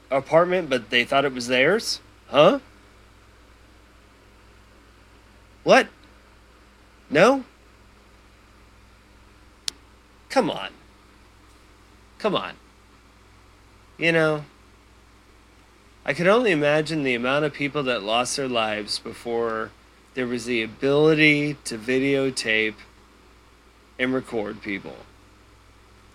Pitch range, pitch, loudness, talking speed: 100-125 Hz, 105 Hz, -22 LUFS, 85 wpm